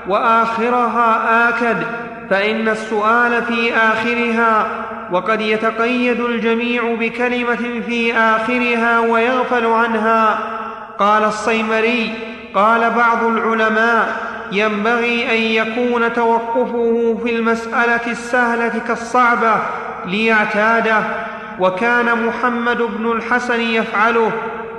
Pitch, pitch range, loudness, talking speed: 230 Hz, 220-235 Hz, -16 LUFS, 80 wpm